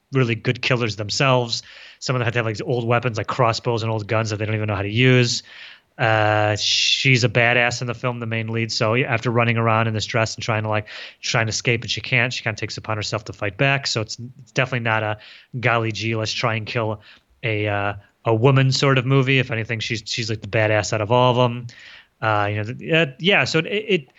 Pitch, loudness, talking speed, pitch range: 115 Hz, -20 LUFS, 255 wpm, 110-125 Hz